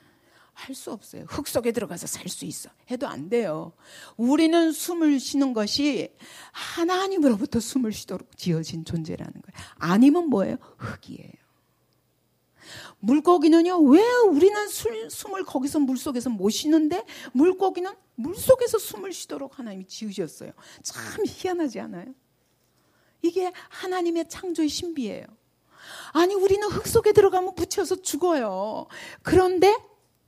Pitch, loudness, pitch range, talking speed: 320 Hz, -23 LUFS, 255-370 Hz, 295 characters per minute